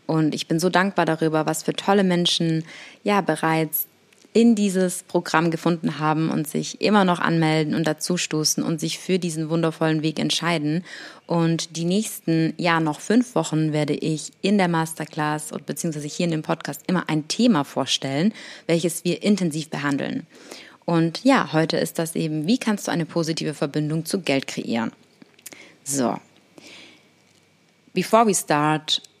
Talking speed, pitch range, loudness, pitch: 155 wpm, 155-180 Hz, -22 LUFS, 165 Hz